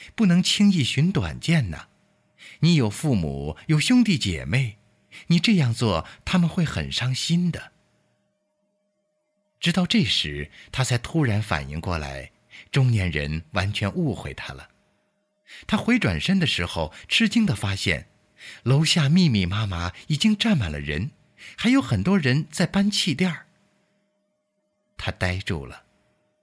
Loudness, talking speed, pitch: -23 LUFS, 200 characters per minute, 150 Hz